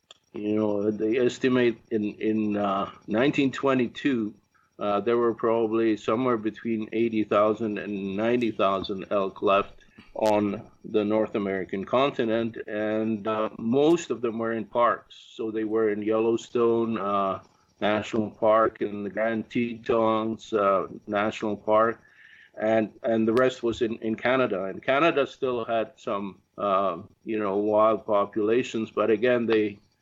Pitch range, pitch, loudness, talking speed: 105-115 Hz, 110 Hz, -26 LUFS, 140 wpm